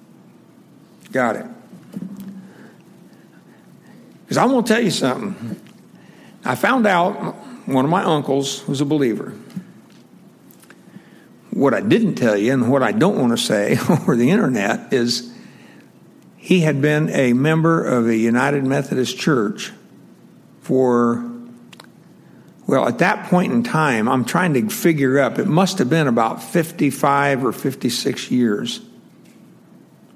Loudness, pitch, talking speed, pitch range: -18 LUFS, 155 Hz, 130 wpm, 135-195 Hz